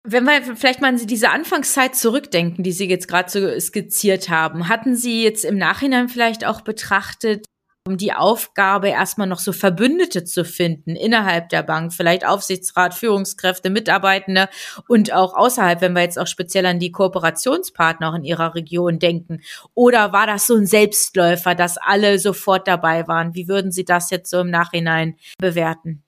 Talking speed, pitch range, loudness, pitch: 170 wpm, 175-220 Hz, -17 LUFS, 190 Hz